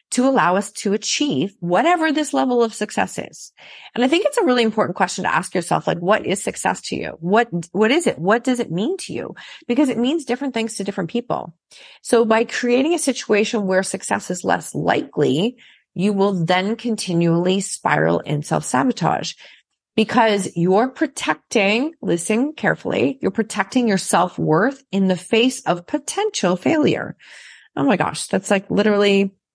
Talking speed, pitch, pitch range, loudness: 170 wpm, 220 Hz, 190-250 Hz, -19 LUFS